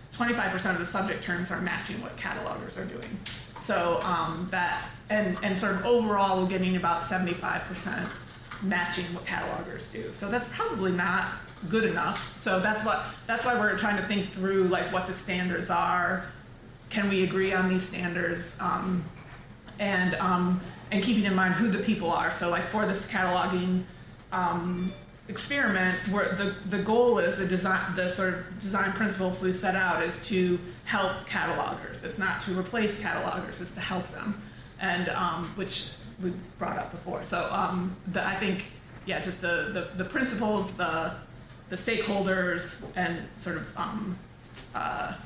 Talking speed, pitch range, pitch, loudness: 165 wpm, 180-200 Hz, 185 Hz, -29 LUFS